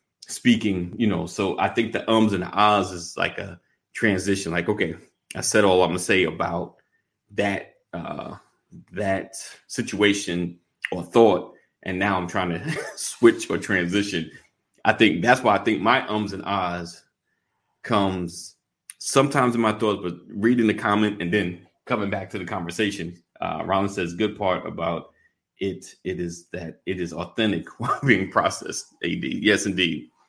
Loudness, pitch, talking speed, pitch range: -23 LUFS, 95 Hz, 165 wpm, 90-105 Hz